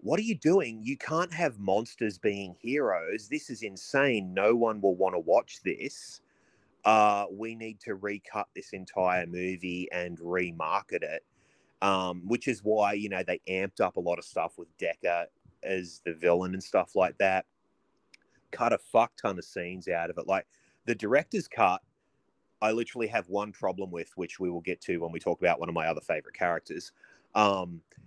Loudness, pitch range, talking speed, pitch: -30 LUFS, 90-110 Hz, 190 wpm, 95 Hz